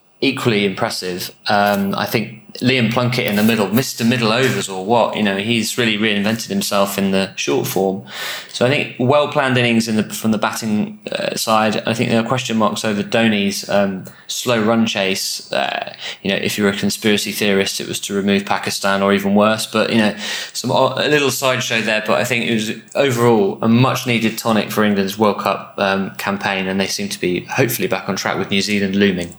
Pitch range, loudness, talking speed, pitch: 100-120 Hz, -17 LUFS, 205 wpm, 110 Hz